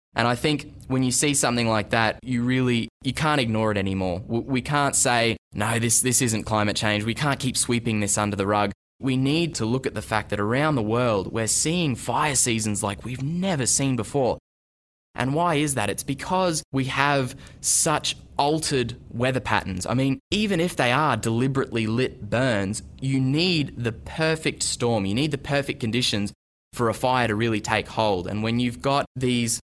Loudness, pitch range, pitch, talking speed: -23 LUFS, 110-140 Hz, 120 Hz, 195 wpm